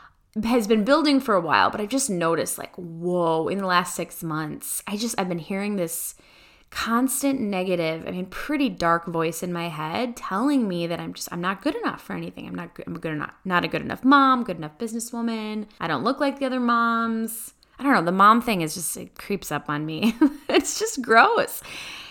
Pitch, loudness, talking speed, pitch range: 205 Hz, -23 LUFS, 220 wpm, 175-245 Hz